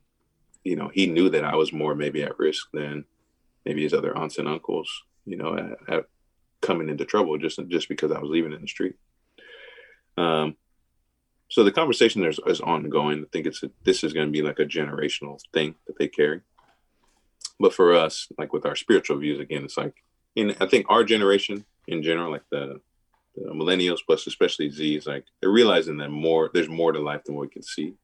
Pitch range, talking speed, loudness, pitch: 75-80 Hz, 205 wpm, -24 LUFS, 75 Hz